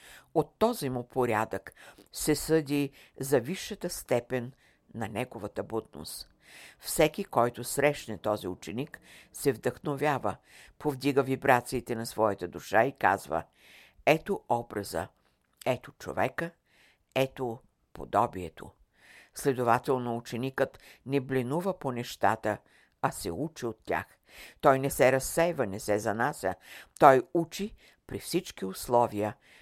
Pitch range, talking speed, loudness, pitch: 110-145 Hz, 110 wpm, -30 LUFS, 125 Hz